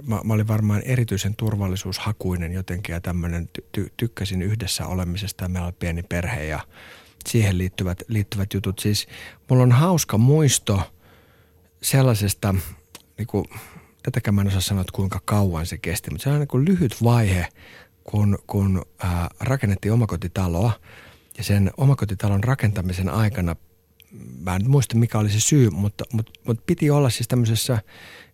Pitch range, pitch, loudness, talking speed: 90-115 Hz, 100 Hz, -22 LUFS, 150 wpm